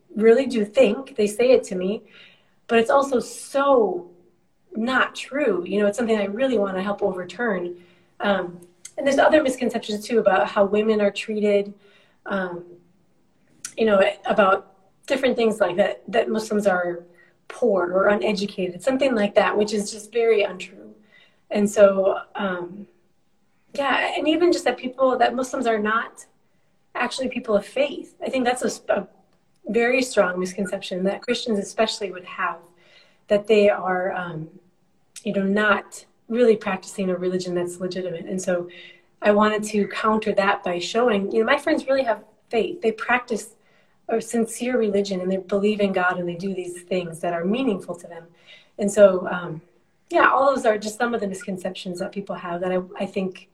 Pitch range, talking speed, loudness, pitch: 185-230 Hz, 175 wpm, -22 LUFS, 205 Hz